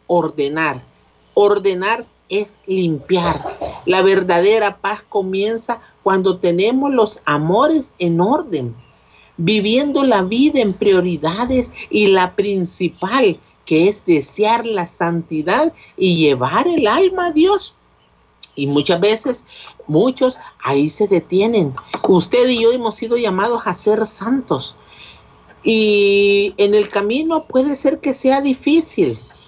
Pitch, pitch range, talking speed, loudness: 200 Hz, 175-240 Hz, 120 wpm, -16 LUFS